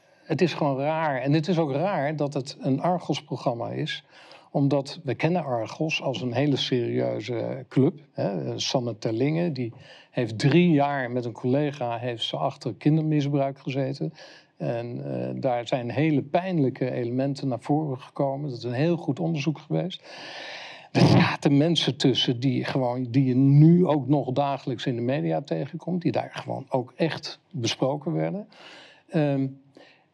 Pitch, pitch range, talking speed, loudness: 140 Hz, 125-155 Hz, 160 wpm, -25 LUFS